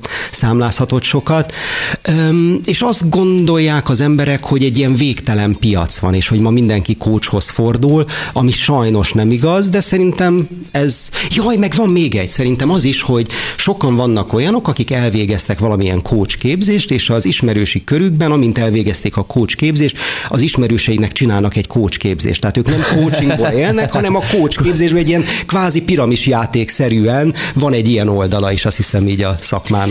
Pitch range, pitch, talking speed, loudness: 110-155 Hz, 125 Hz, 160 wpm, -13 LUFS